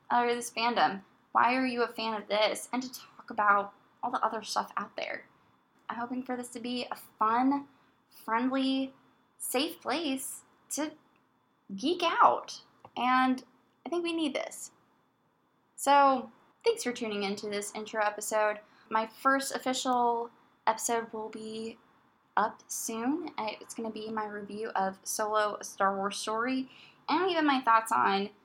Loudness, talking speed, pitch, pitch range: -31 LUFS, 150 wpm, 235 Hz, 215-265 Hz